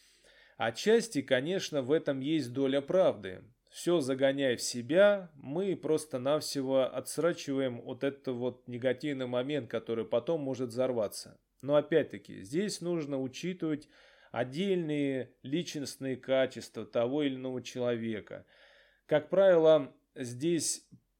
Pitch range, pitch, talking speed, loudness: 125-160 Hz, 140 Hz, 110 wpm, -32 LUFS